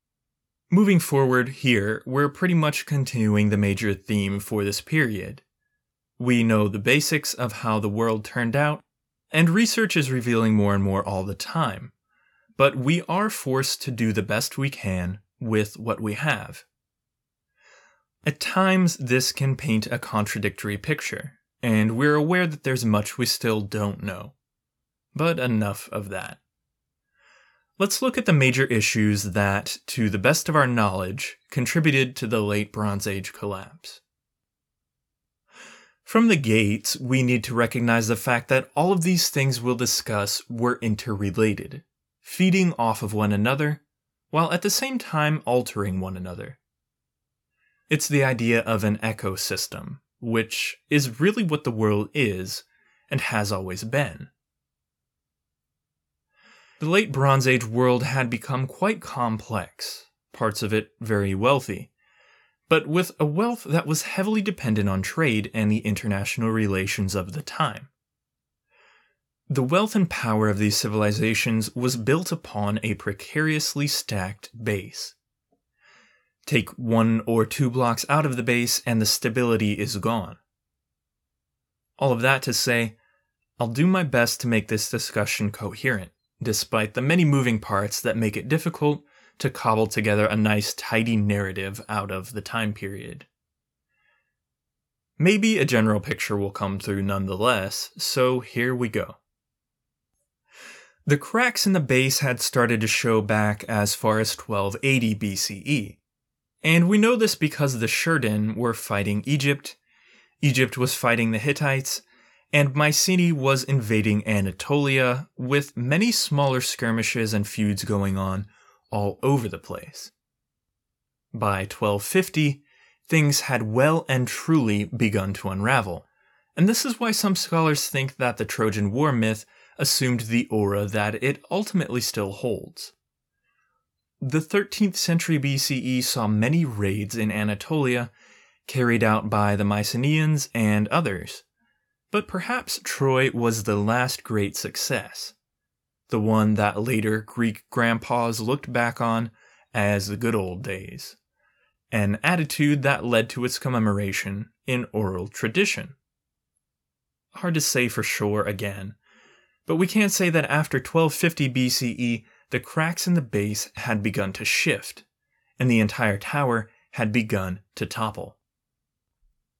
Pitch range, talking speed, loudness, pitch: 105-145 Hz, 140 wpm, -23 LUFS, 120 Hz